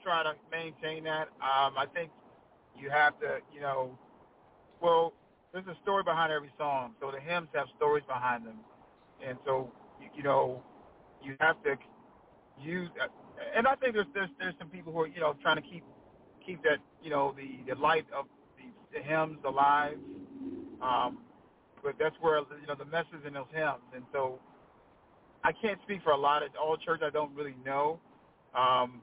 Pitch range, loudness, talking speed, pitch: 135-170 Hz, -32 LUFS, 185 wpm, 155 Hz